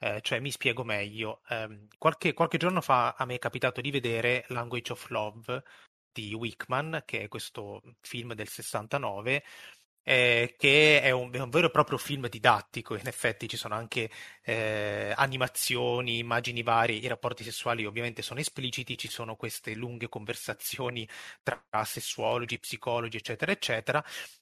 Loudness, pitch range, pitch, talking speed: -29 LUFS, 115-130 Hz, 120 Hz, 155 wpm